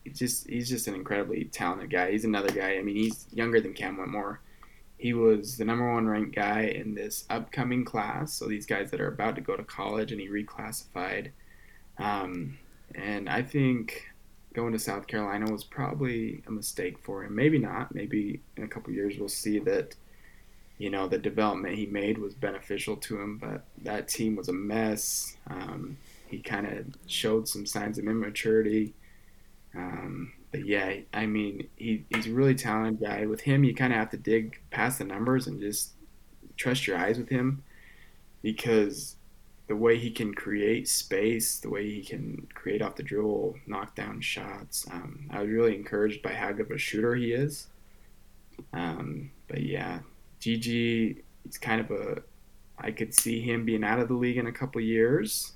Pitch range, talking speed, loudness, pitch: 105-115 Hz, 185 wpm, -30 LUFS, 110 Hz